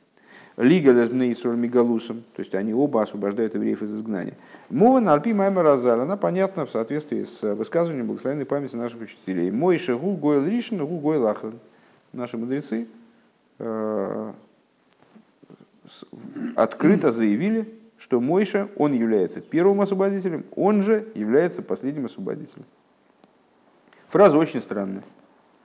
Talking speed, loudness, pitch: 105 wpm, -22 LUFS, 135 Hz